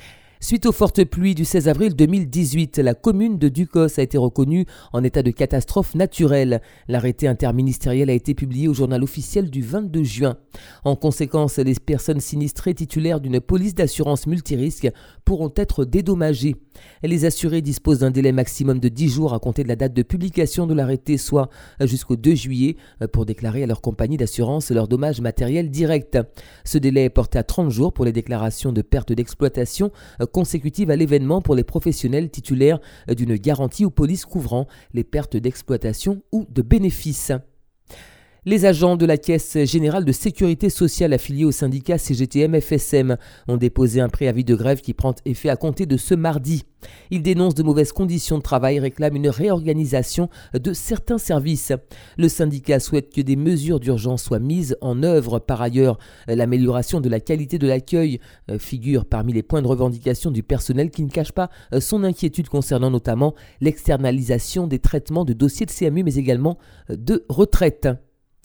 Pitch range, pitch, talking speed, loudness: 130-165 Hz, 145 Hz, 170 wpm, -20 LUFS